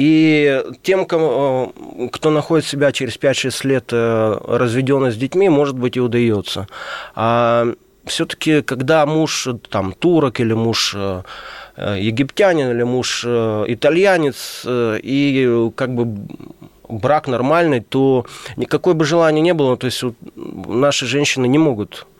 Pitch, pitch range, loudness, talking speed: 130 Hz, 120-150 Hz, -16 LUFS, 120 wpm